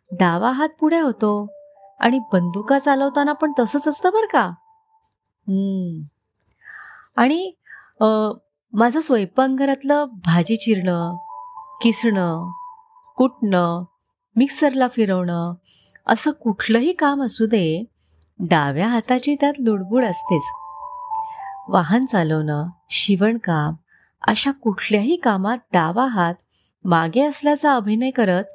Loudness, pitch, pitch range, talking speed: -20 LUFS, 225 Hz, 180-280 Hz, 90 wpm